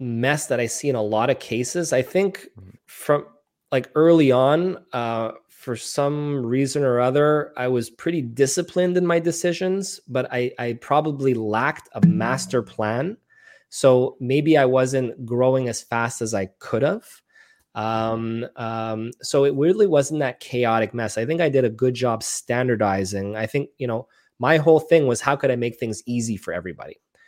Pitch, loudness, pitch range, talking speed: 130 Hz, -22 LUFS, 115-150 Hz, 180 wpm